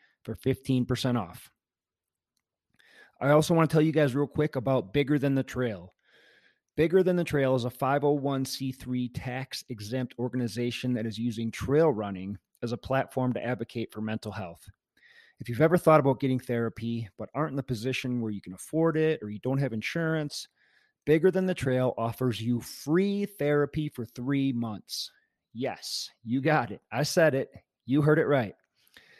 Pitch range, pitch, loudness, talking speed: 120-150 Hz, 130 Hz, -28 LUFS, 175 wpm